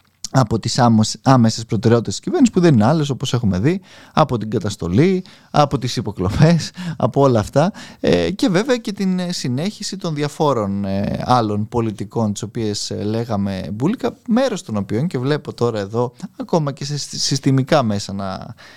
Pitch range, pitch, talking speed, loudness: 110-170 Hz, 130 Hz, 155 wpm, -18 LUFS